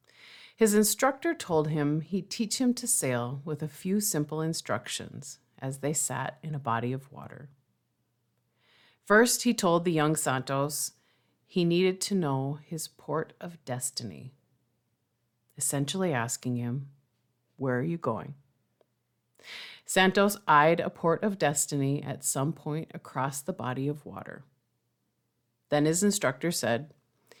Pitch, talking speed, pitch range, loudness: 150 Hz, 135 wpm, 130-170 Hz, -28 LUFS